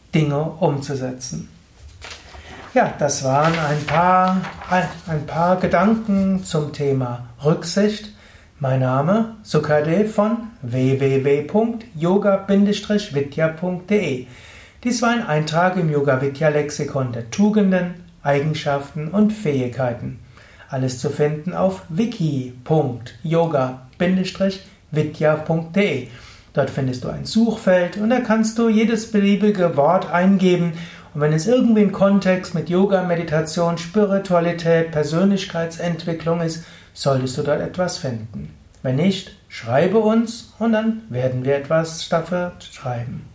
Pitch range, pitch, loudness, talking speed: 140-195 Hz, 165 Hz, -20 LUFS, 105 wpm